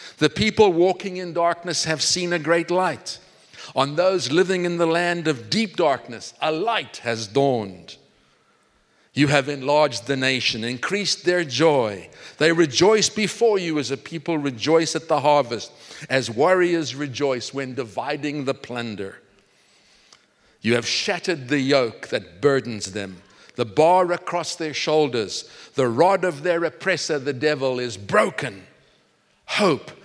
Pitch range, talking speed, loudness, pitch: 130-175 Hz, 145 wpm, -21 LUFS, 150 Hz